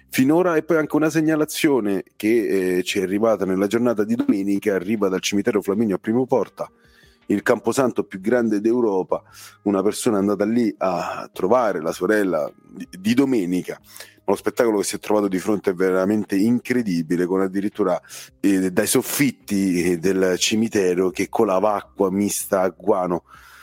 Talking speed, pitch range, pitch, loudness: 165 wpm, 95-120 Hz, 105 Hz, -21 LUFS